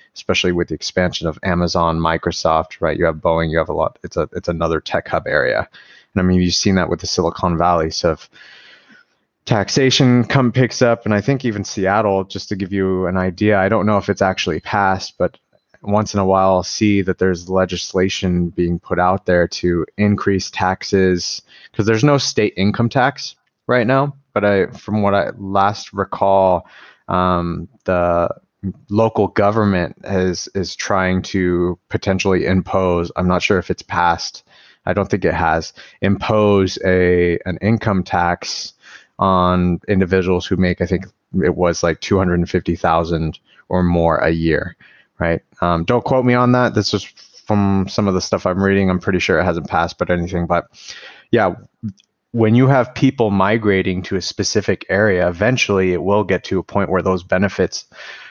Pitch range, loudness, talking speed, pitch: 90-105 Hz, -17 LUFS, 180 wpm, 95 Hz